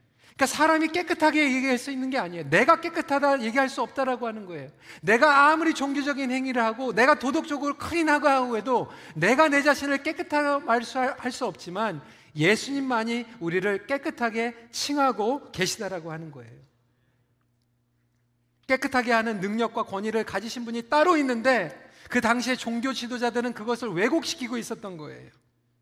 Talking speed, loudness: 365 characters per minute, -25 LUFS